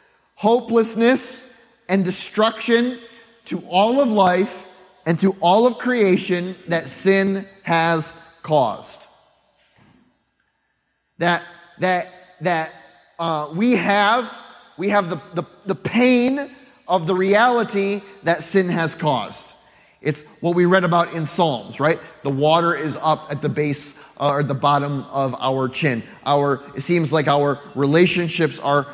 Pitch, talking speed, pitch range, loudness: 175 Hz, 135 wpm, 155-205 Hz, -19 LUFS